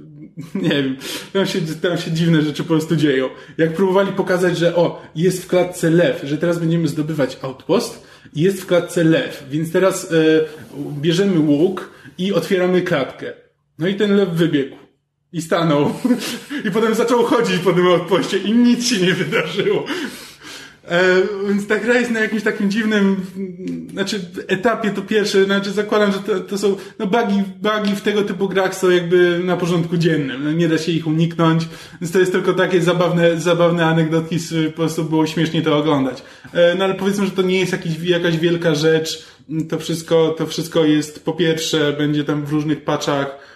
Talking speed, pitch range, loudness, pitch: 180 wpm, 160-195 Hz, -18 LUFS, 175 Hz